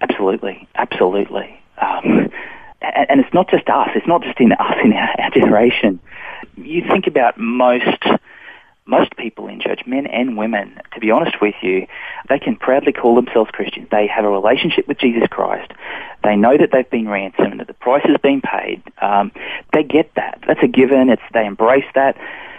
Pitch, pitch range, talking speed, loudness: 125 Hz, 105-140 Hz, 180 wpm, -15 LUFS